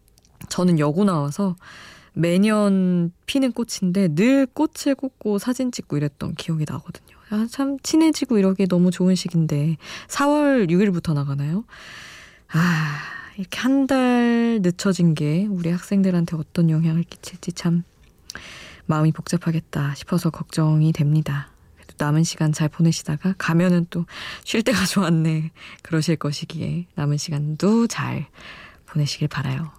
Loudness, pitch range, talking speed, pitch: -21 LUFS, 155-200 Hz, 290 characters per minute, 170 Hz